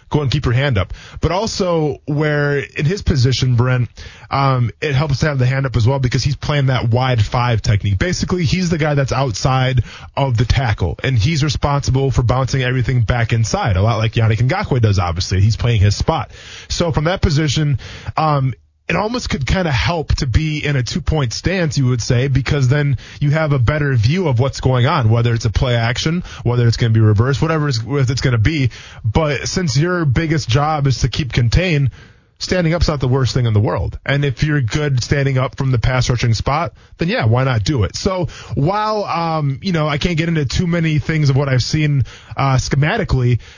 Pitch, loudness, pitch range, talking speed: 130 Hz, -17 LUFS, 115-150 Hz, 220 wpm